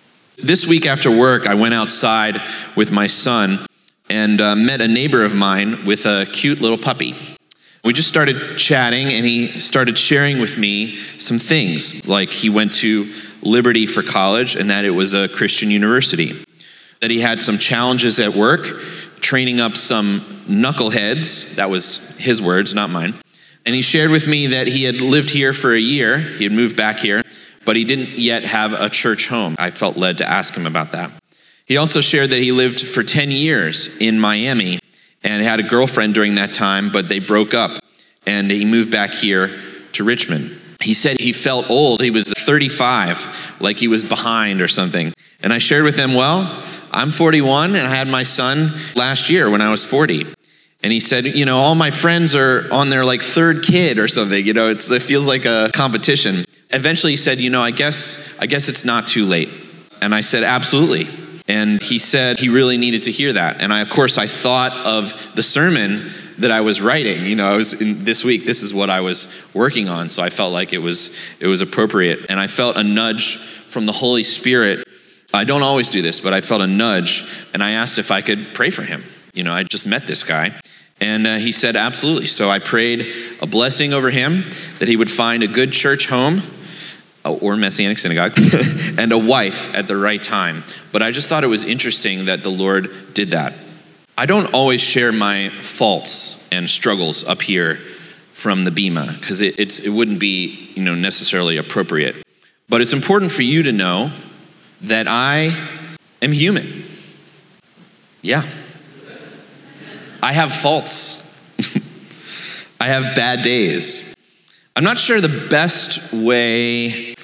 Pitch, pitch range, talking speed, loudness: 120 Hz, 105-140 Hz, 190 wpm, -14 LUFS